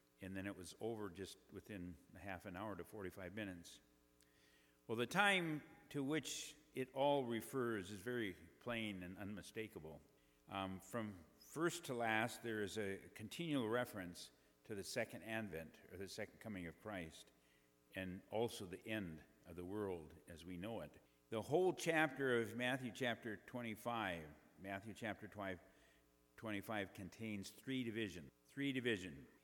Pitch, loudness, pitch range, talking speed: 105 Hz, -45 LUFS, 90-120 Hz, 145 wpm